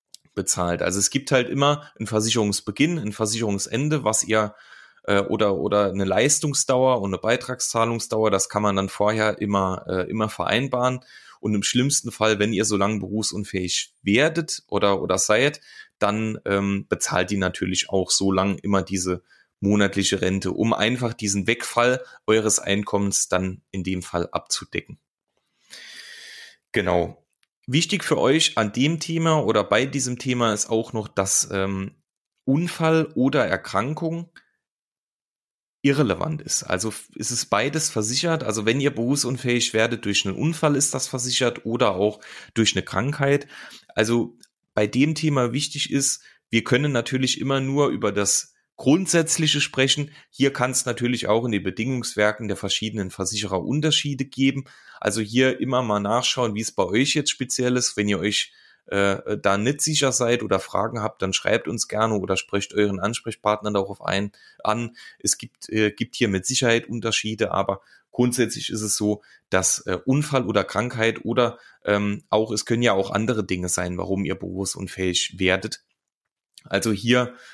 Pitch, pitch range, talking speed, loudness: 110 Hz, 100-130 Hz, 155 wpm, -22 LUFS